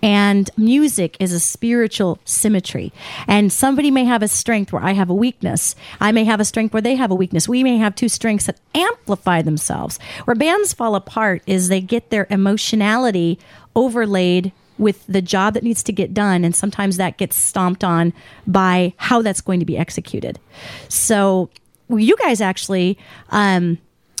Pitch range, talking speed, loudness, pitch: 185-225 Hz, 180 wpm, -17 LUFS, 200 Hz